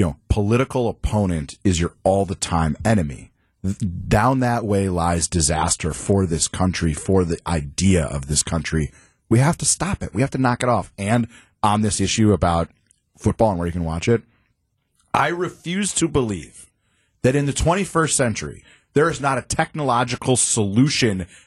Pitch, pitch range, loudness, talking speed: 100 Hz, 85-120 Hz, -20 LUFS, 180 wpm